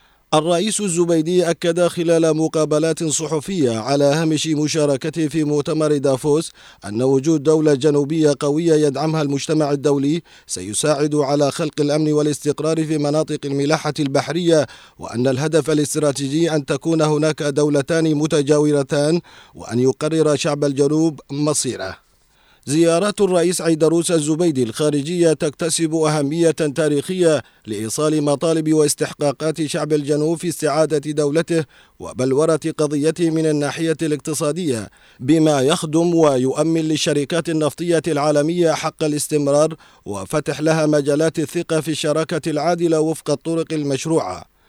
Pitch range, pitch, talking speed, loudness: 145-160 Hz, 155 Hz, 110 wpm, -18 LUFS